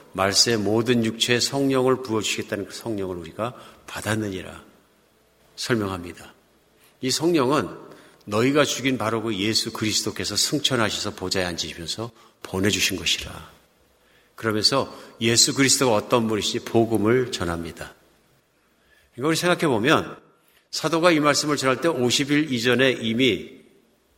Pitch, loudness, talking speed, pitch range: 115 Hz, -22 LUFS, 295 characters per minute, 95-130 Hz